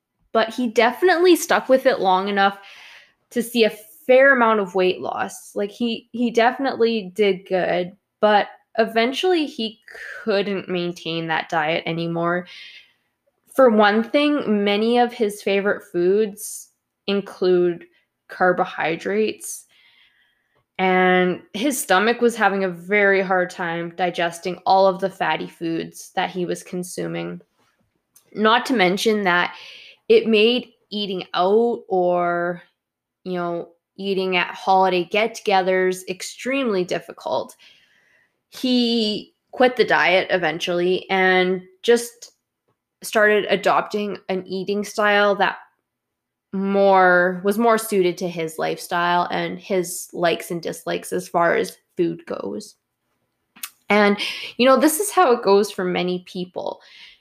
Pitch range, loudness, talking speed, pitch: 180-225 Hz, -20 LUFS, 125 wpm, 195 Hz